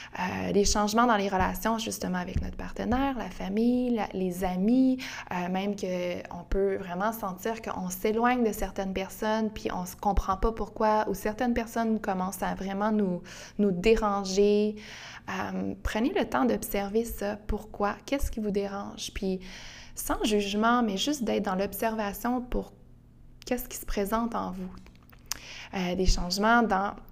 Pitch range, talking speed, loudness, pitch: 190-225 Hz, 155 wpm, -29 LUFS, 205 Hz